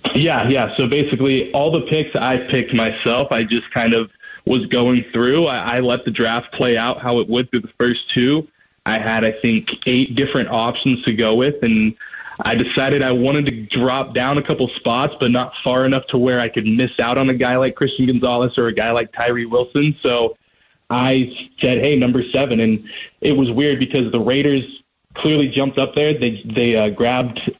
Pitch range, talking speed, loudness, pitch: 120-135 Hz, 205 wpm, -17 LUFS, 125 Hz